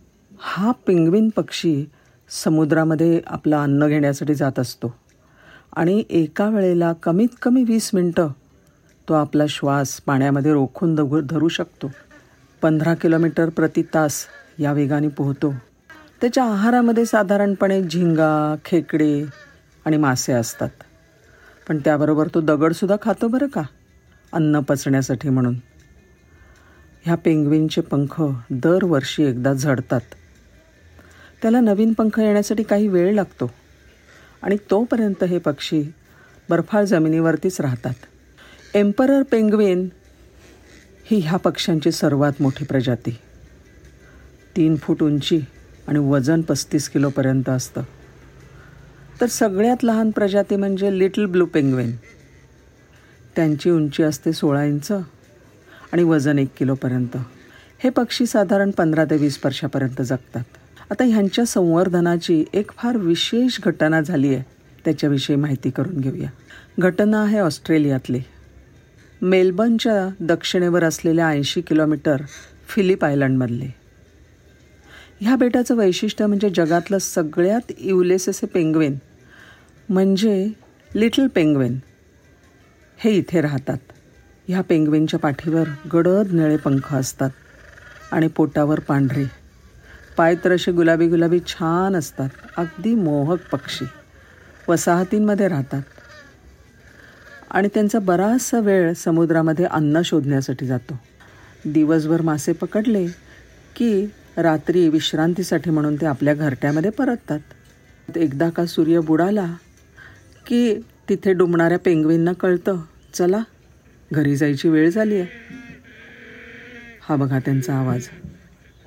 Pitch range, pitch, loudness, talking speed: 140-185 Hz, 160 Hz, -19 LUFS, 105 wpm